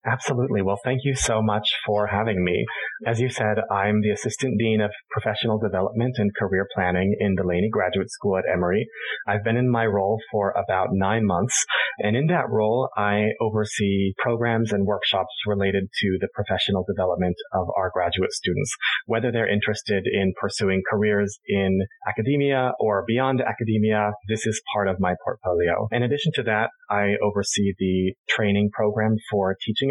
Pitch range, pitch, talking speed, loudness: 100-110 Hz, 105 Hz, 165 wpm, -23 LUFS